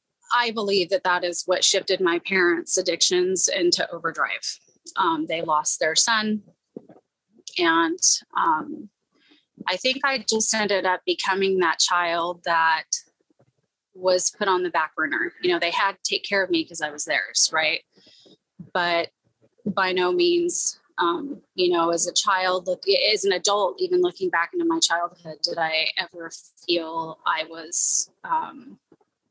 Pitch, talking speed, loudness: 185 Hz, 155 wpm, -22 LUFS